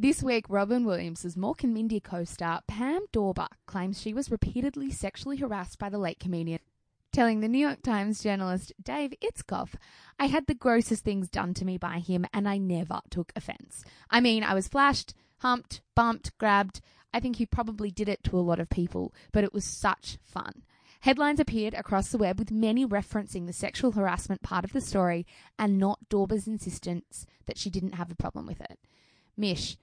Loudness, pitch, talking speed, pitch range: -30 LUFS, 205 Hz, 190 wpm, 185-235 Hz